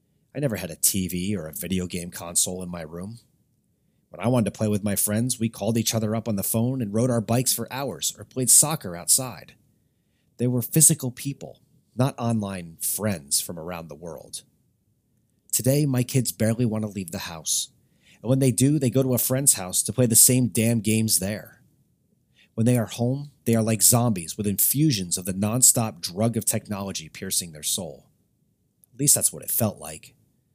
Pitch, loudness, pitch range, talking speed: 115 Hz, -22 LUFS, 100-125 Hz, 200 wpm